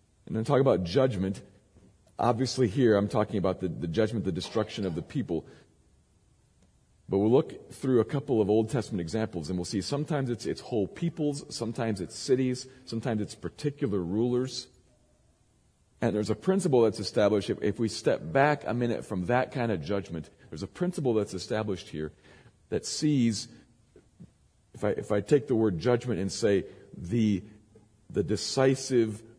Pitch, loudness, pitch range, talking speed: 110 Hz, -29 LUFS, 100-130 Hz, 170 wpm